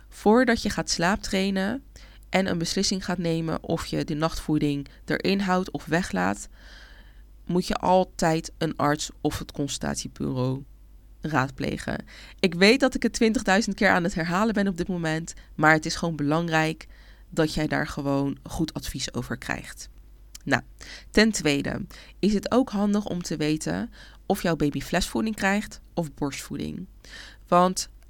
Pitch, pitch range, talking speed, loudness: 170 Hz, 150-195 Hz, 150 wpm, -25 LUFS